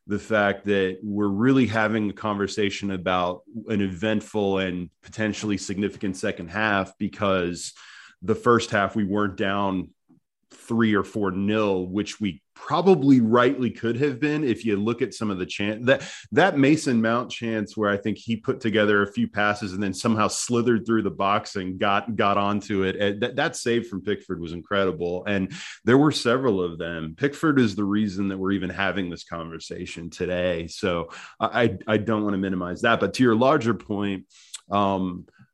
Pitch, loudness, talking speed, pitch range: 105 Hz, -24 LUFS, 180 wpm, 95-115 Hz